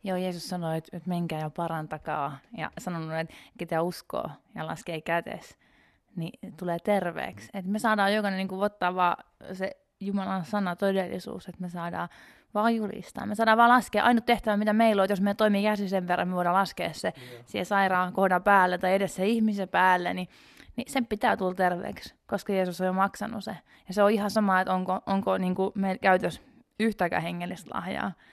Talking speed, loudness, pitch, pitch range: 180 wpm, -27 LUFS, 190 Hz, 180-210 Hz